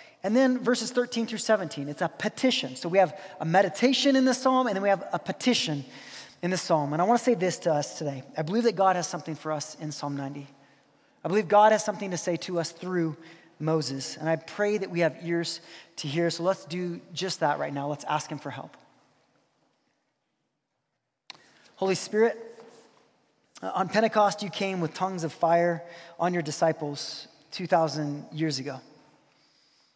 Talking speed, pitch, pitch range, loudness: 190 wpm, 175 Hz, 155-205 Hz, -27 LUFS